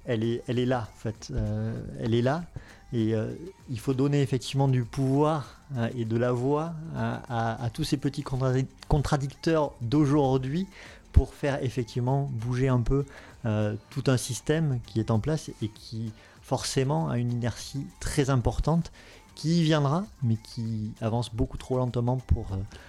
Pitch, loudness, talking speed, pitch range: 125 Hz, -28 LUFS, 175 wpm, 115-140 Hz